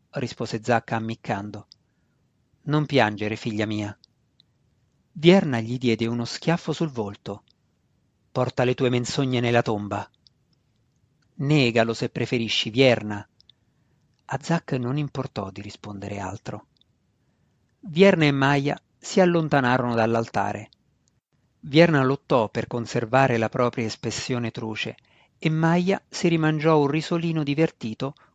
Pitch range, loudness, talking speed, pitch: 115-145 Hz, -23 LUFS, 110 wpm, 125 Hz